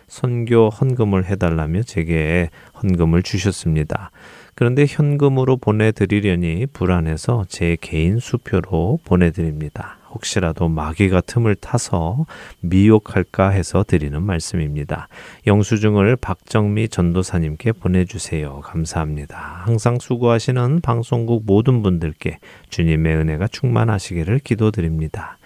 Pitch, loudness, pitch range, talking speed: 95 Hz, -18 LUFS, 85-115 Hz, 300 characters per minute